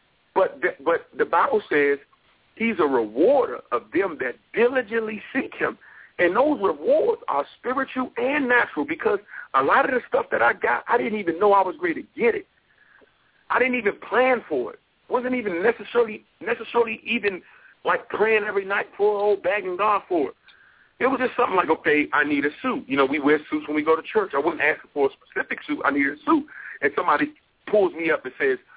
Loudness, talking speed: -23 LUFS, 210 wpm